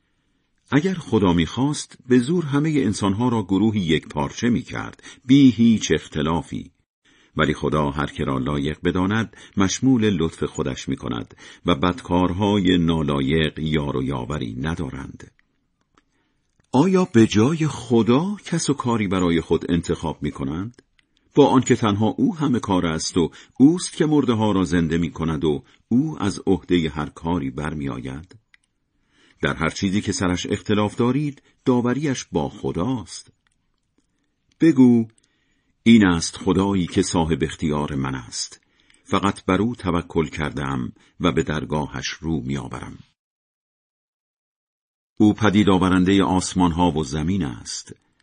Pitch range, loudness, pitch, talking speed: 80-115 Hz, -21 LUFS, 95 Hz, 130 wpm